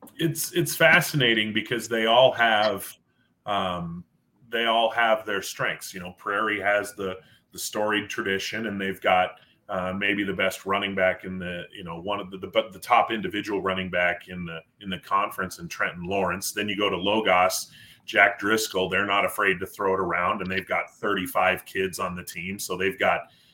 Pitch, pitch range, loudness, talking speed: 100 Hz, 90-110 Hz, -24 LUFS, 195 wpm